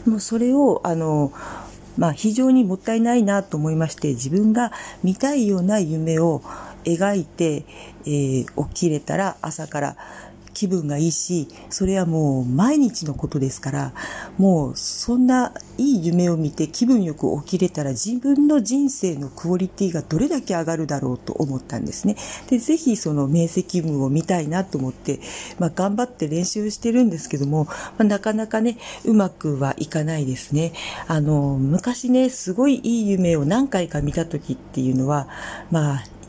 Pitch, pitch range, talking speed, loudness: 175 Hz, 150-220 Hz, 325 characters per minute, -21 LUFS